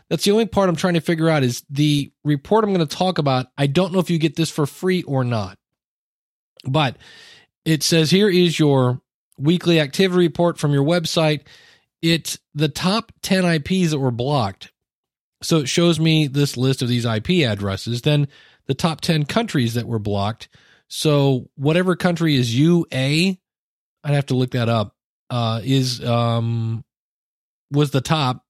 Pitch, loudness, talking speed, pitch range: 150 Hz, -19 LUFS, 175 wpm, 125-170 Hz